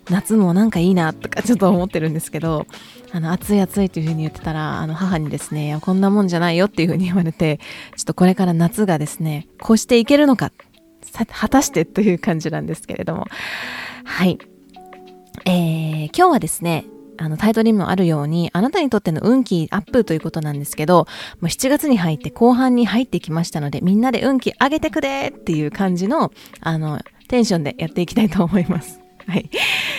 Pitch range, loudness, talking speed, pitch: 160-215 Hz, -18 LUFS, 425 characters per minute, 180 Hz